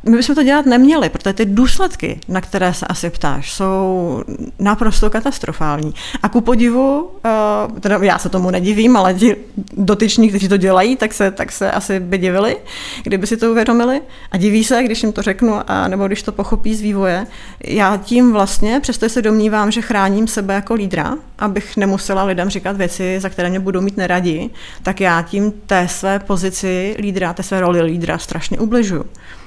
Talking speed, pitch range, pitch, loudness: 185 wpm, 190-225 Hz, 205 Hz, -15 LUFS